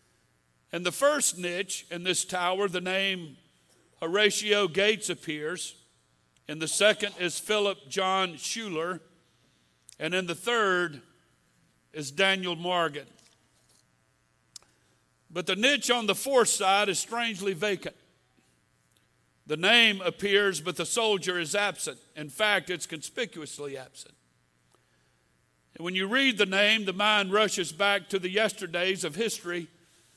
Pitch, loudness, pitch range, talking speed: 180 Hz, -26 LUFS, 145-200 Hz, 125 wpm